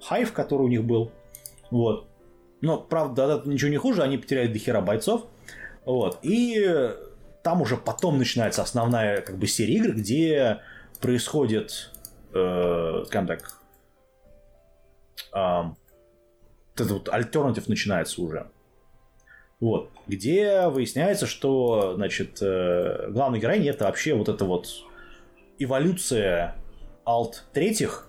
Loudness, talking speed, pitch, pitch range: -25 LUFS, 105 wpm, 120 Hz, 95-140 Hz